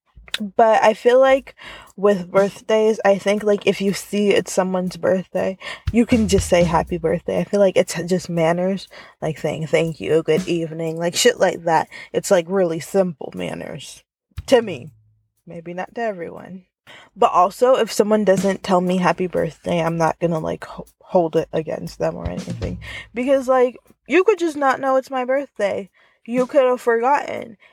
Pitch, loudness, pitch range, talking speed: 190 Hz, -19 LUFS, 170-235 Hz, 175 wpm